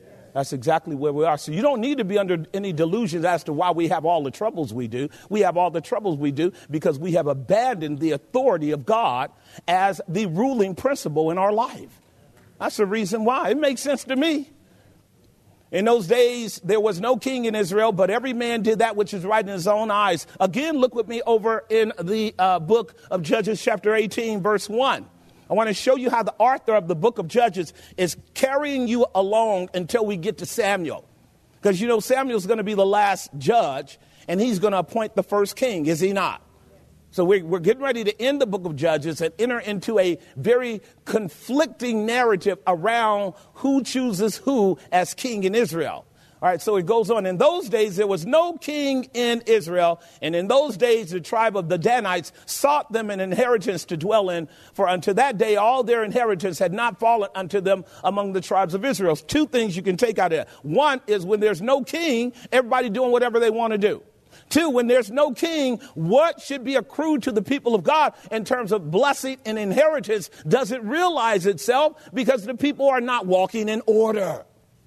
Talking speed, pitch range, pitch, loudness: 210 wpm, 185-245 Hz, 220 Hz, -22 LUFS